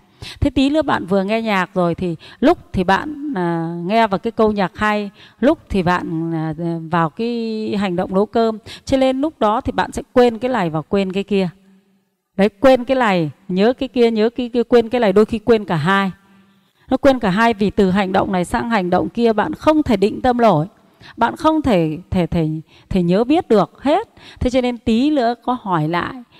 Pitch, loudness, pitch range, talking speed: 210 Hz, -17 LUFS, 185-245 Hz, 225 wpm